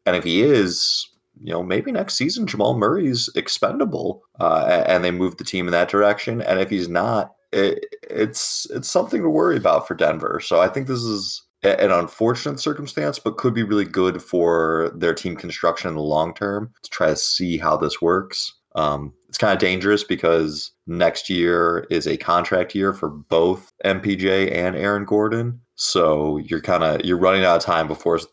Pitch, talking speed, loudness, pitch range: 95 Hz, 190 wpm, -20 LUFS, 85-105 Hz